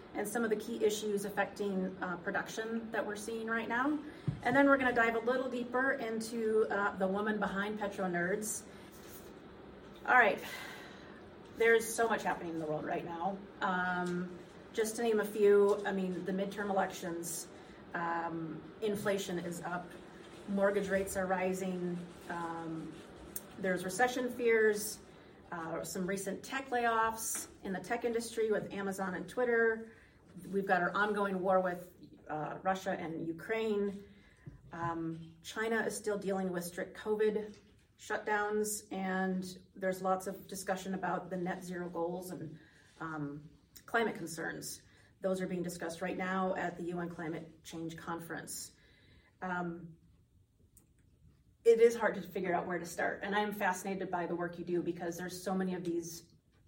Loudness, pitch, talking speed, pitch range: -35 LUFS, 190 Hz, 155 wpm, 175-210 Hz